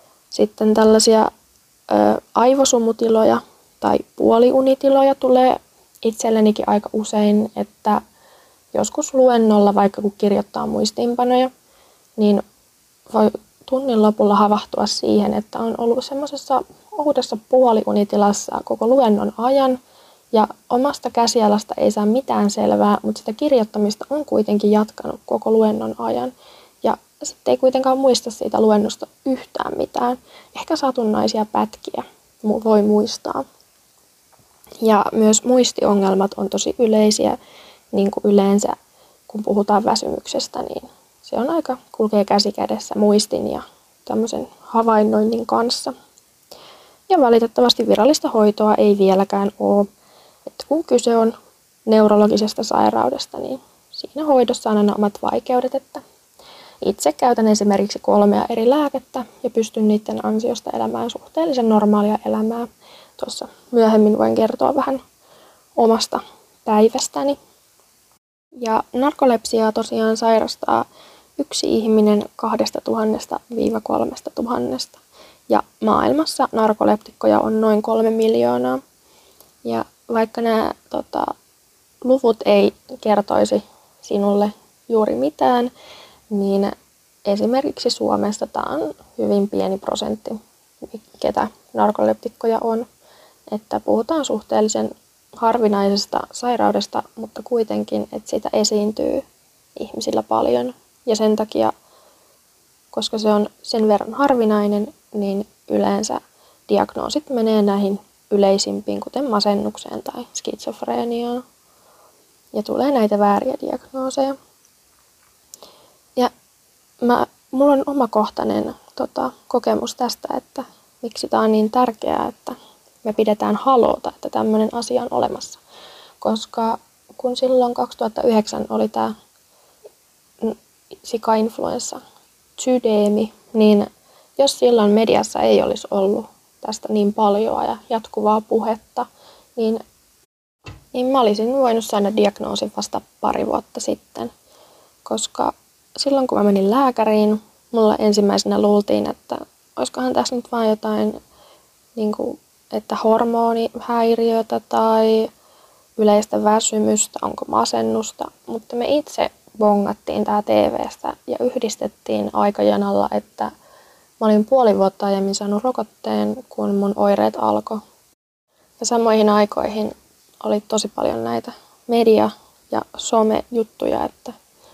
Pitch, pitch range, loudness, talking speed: 220 Hz, 205-245 Hz, -18 LUFS, 105 wpm